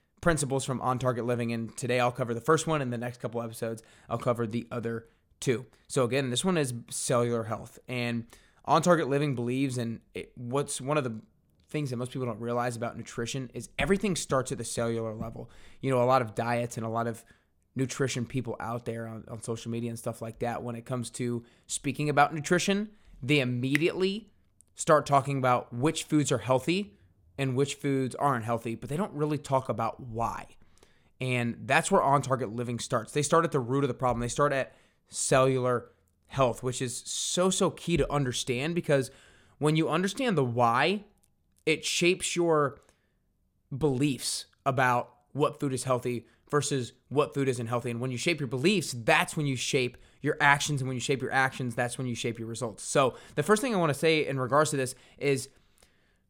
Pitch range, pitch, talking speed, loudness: 120-145 Hz, 130 Hz, 200 wpm, -29 LUFS